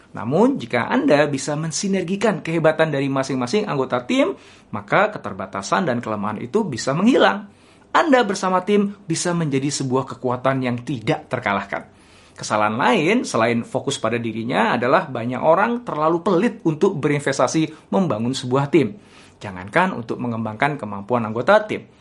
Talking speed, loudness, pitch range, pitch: 135 wpm, -20 LUFS, 125-175 Hz, 140 Hz